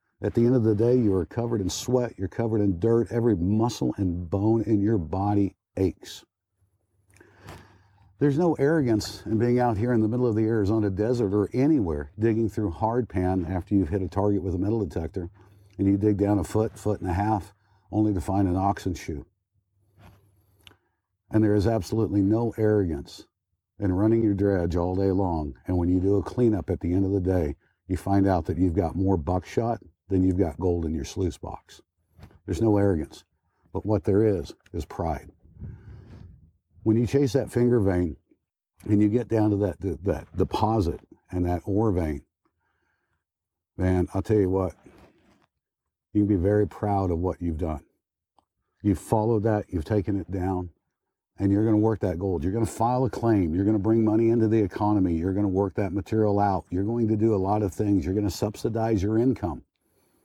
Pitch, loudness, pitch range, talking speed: 100 Hz, -25 LUFS, 95-110 Hz, 195 wpm